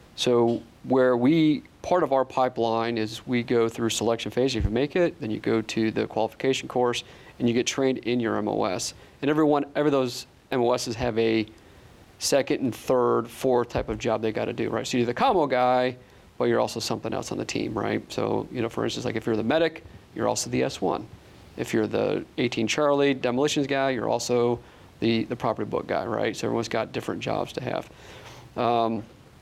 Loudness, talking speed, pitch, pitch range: -25 LUFS, 210 wpm, 120 Hz, 110-130 Hz